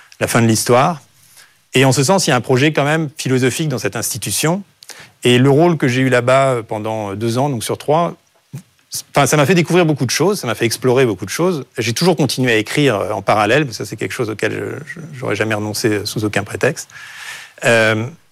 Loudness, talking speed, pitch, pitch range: -16 LUFS, 225 wpm, 130 Hz, 115-150 Hz